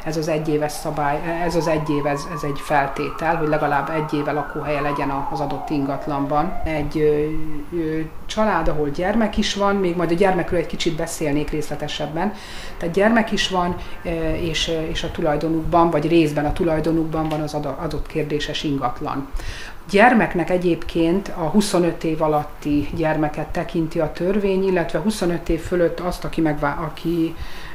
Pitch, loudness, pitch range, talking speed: 160 Hz, -21 LUFS, 150-170 Hz, 155 wpm